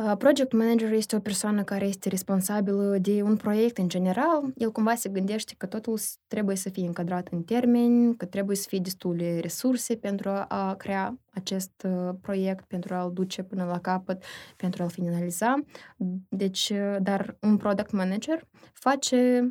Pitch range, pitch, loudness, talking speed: 185-225 Hz, 200 Hz, -27 LUFS, 155 wpm